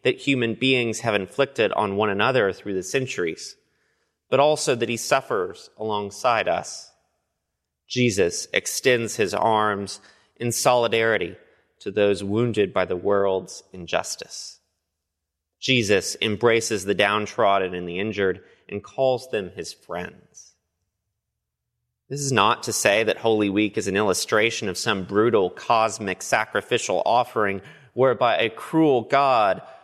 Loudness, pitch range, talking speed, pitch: -22 LUFS, 95-125 Hz, 130 wpm, 105 Hz